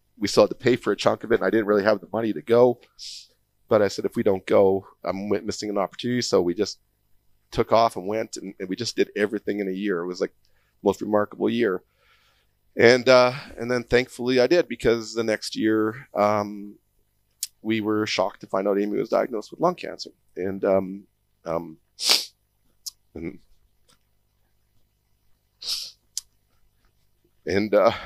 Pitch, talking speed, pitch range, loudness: 105 Hz, 175 wpm, 100-115 Hz, -23 LUFS